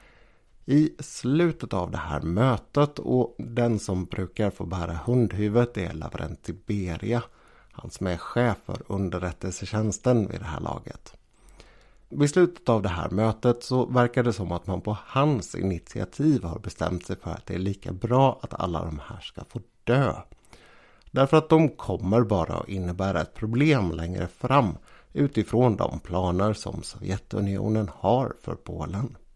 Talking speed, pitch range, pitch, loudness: 155 wpm, 90-120 Hz, 105 Hz, -26 LUFS